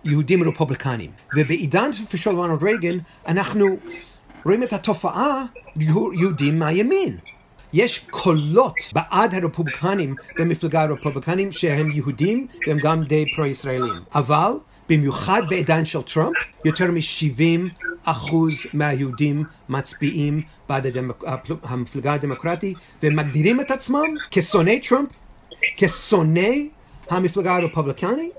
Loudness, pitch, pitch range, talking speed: -21 LUFS, 165 Hz, 150-195 Hz, 95 wpm